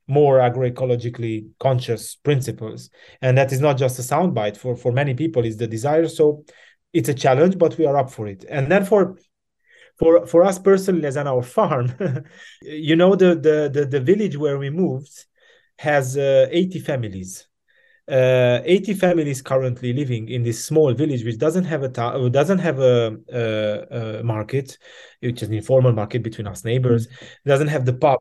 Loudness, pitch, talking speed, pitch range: -19 LUFS, 135 Hz, 180 wpm, 120-160 Hz